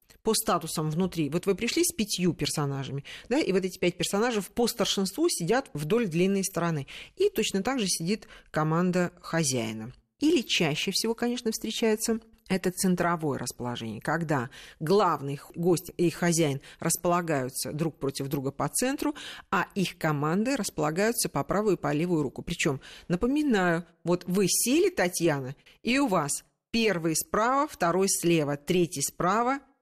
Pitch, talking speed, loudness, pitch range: 175 Hz, 145 wpm, -27 LUFS, 155-215 Hz